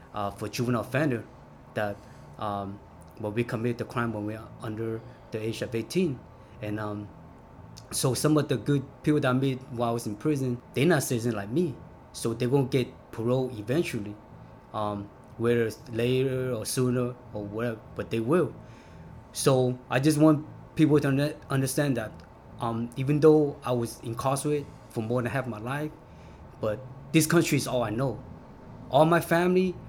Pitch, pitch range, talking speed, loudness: 125 Hz, 110-135 Hz, 175 wpm, -28 LUFS